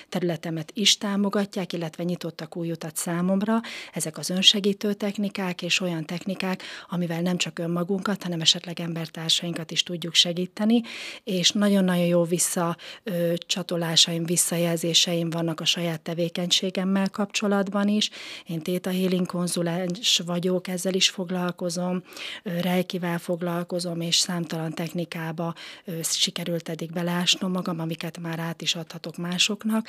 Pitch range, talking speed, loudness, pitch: 170-190 Hz, 120 wpm, -25 LUFS, 175 Hz